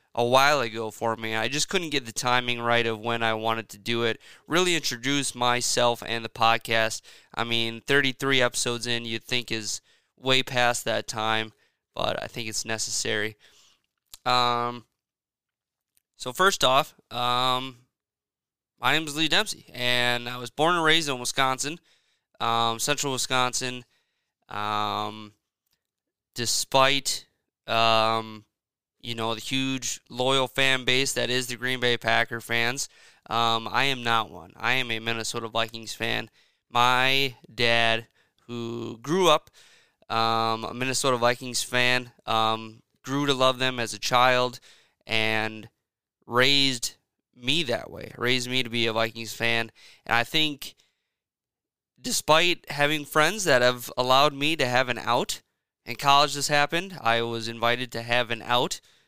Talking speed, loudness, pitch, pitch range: 150 wpm, -25 LUFS, 120 Hz, 115-130 Hz